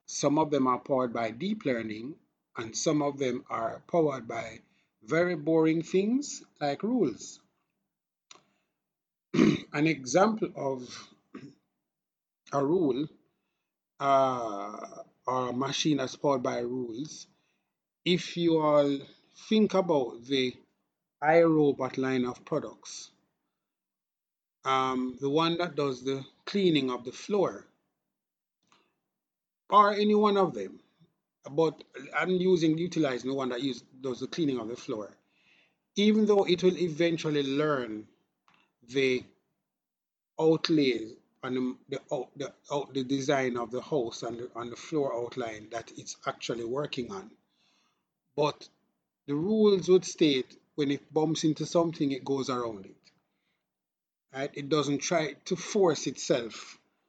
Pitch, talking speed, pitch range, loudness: 145 Hz, 125 wpm, 130-170 Hz, -29 LUFS